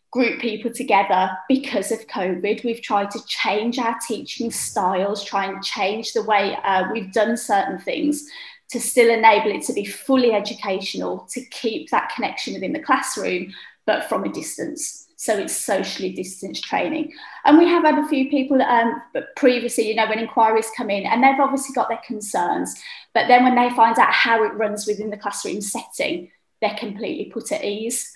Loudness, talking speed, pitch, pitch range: -20 LUFS, 185 wpm, 230 Hz, 210-255 Hz